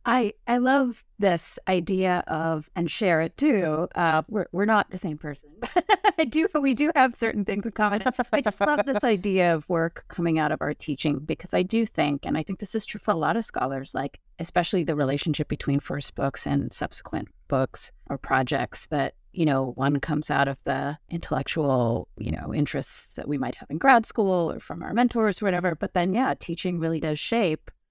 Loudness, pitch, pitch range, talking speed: -25 LUFS, 175 Hz, 150-220 Hz, 210 wpm